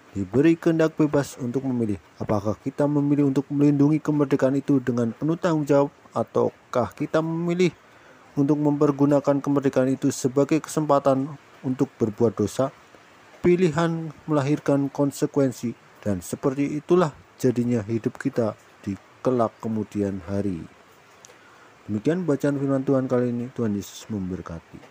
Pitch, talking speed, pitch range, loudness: 135 Hz, 120 wpm, 115-145 Hz, -24 LUFS